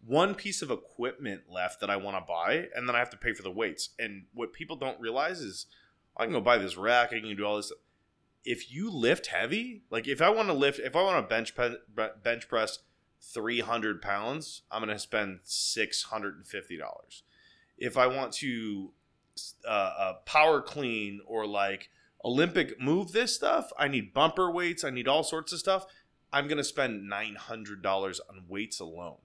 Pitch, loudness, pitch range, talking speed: 120 Hz, -30 LUFS, 105-150 Hz, 215 wpm